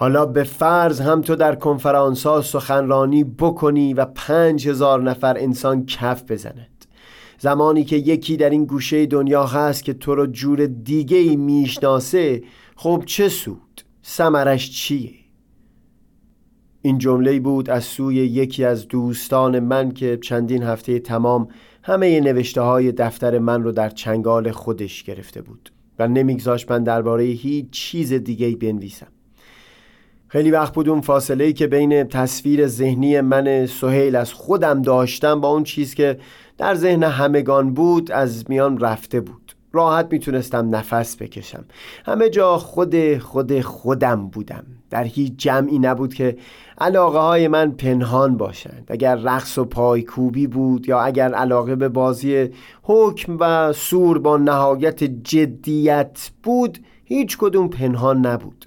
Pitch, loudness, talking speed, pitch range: 135 Hz, -18 LUFS, 140 wpm, 125-150 Hz